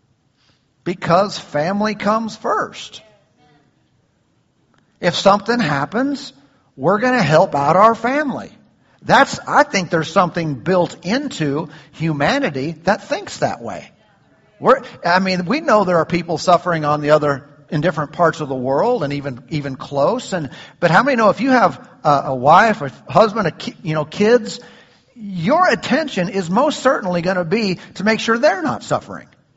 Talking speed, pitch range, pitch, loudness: 160 wpm, 150-220 Hz, 180 Hz, -17 LUFS